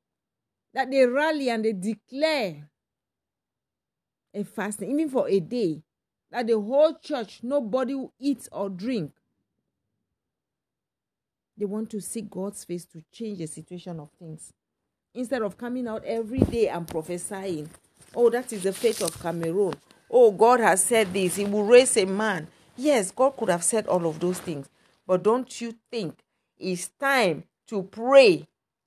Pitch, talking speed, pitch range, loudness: 215 Hz, 155 wpm, 180-250 Hz, -24 LUFS